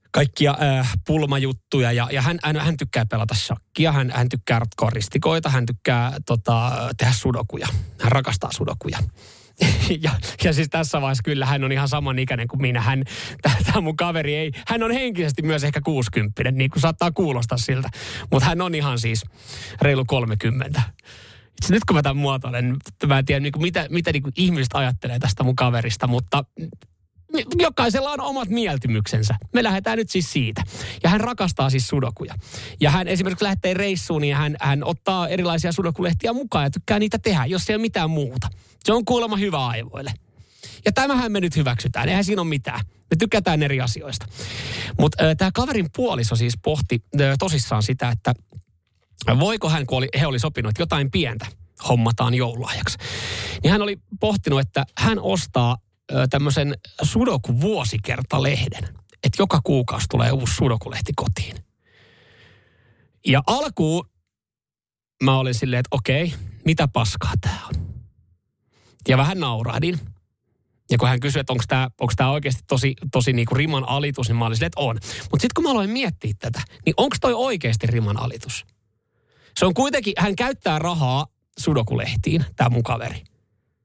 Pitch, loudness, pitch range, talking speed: 130 Hz, -21 LUFS, 115-155 Hz, 160 wpm